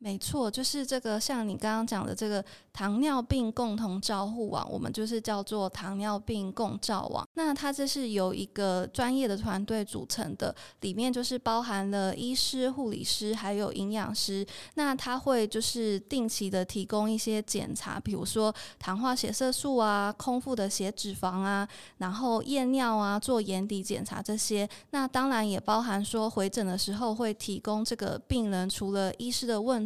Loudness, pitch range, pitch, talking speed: -31 LUFS, 200-245 Hz, 215 Hz, 265 characters per minute